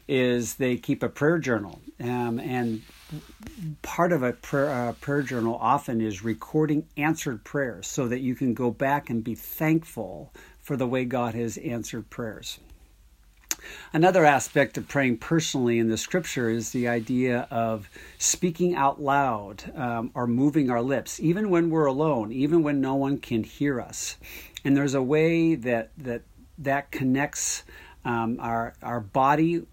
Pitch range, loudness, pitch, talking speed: 115-145 Hz, -26 LUFS, 130 Hz, 160 wpm